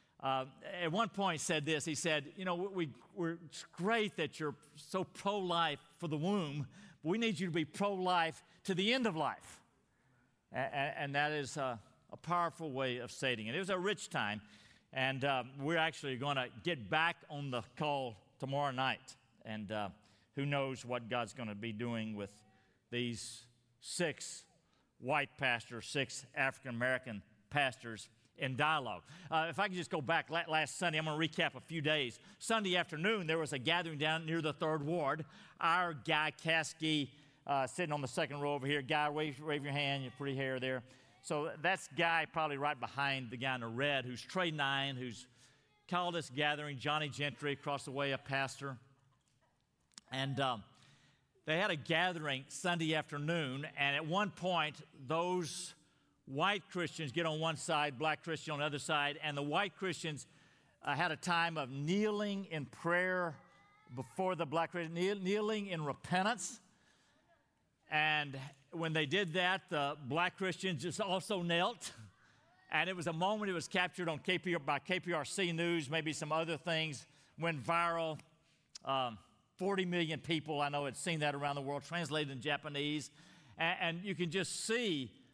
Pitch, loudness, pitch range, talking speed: 155 Hz, -37 LUFS, 135-170 Hz, 175 wpm